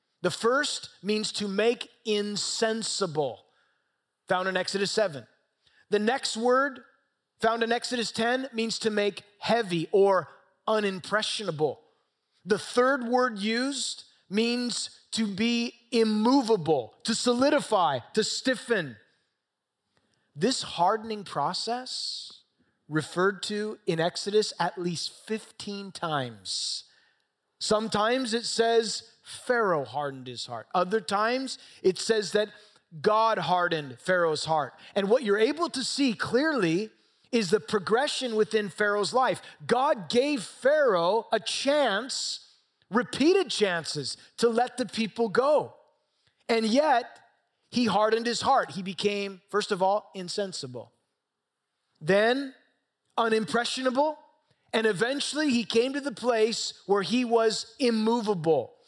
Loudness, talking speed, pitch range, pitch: -27 LUFS, 115 wpm, 195-240 Hz, 220 Hz